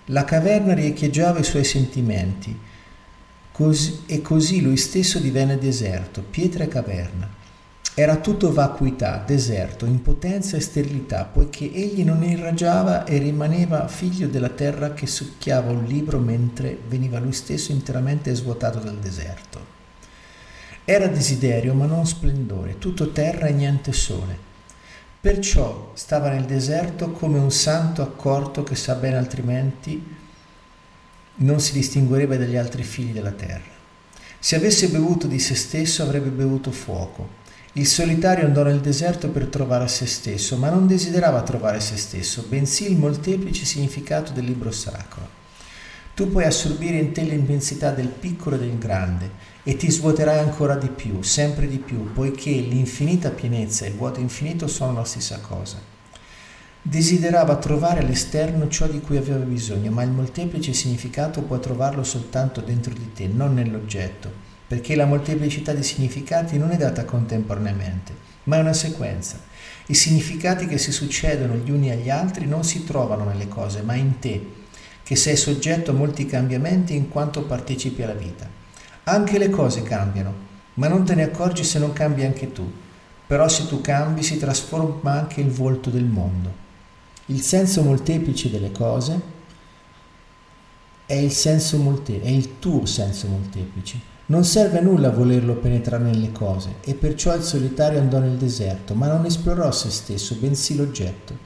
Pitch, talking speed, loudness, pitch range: 135 Hz, 155 wpm, -21 LUFS, 115-155 Hz